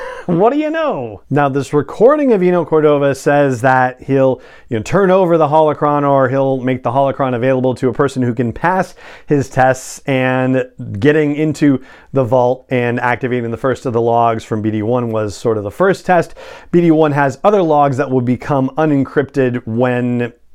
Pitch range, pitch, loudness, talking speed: 125-155 Hz, 135 Hz, -14 LUFS, 180 wpm